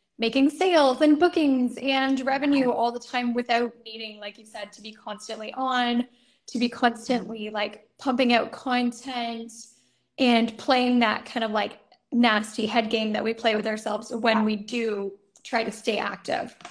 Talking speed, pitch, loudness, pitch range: 165 wpm, 235 Hz, -24 LUFS, 220-250 Hz